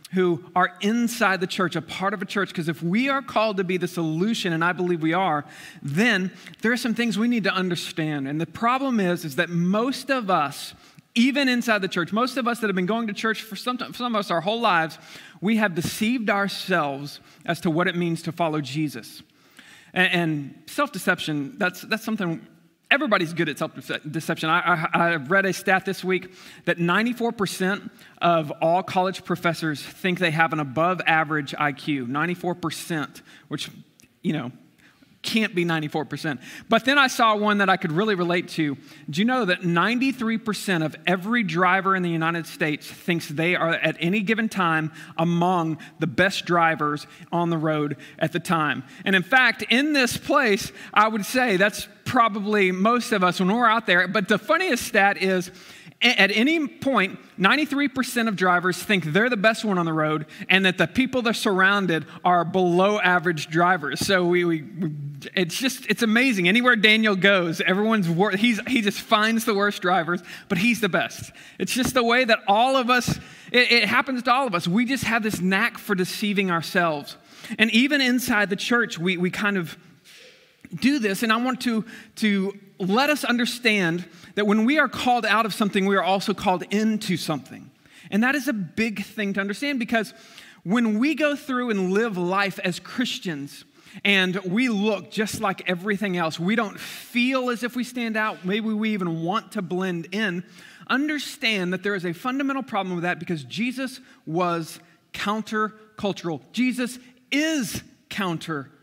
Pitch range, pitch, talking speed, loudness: 170-225 Hz, 195 Hz, 185 wpm, -23 LUFS